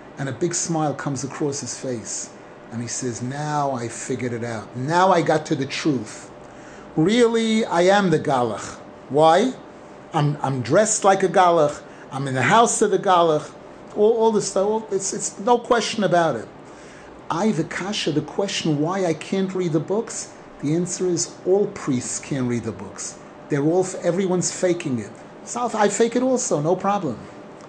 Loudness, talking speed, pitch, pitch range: -21 LUFS, 185 wpm, 165 Hz, 135-195 Hz